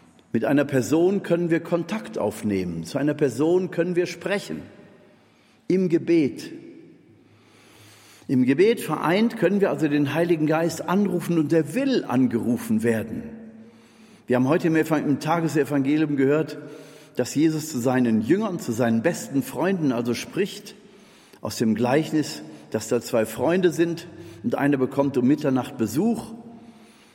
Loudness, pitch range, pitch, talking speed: -23 LUFS, 125-175 Hz, 155 Hz, 135 wpm